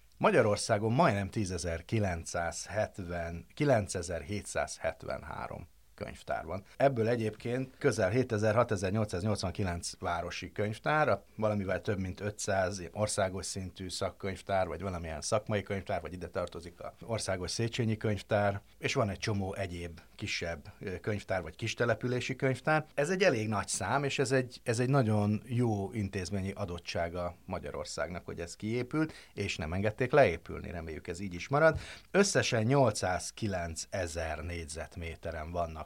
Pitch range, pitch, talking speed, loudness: 90-115 Hz, 105 Hz, 115 wpm, -33 LUFS